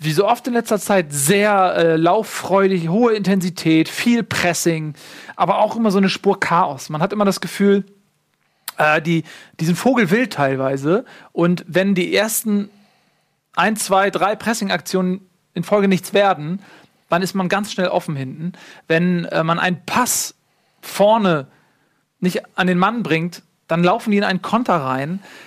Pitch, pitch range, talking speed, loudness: 190 Hz, 170-205 Hz, 160 wpm, -18 LUFS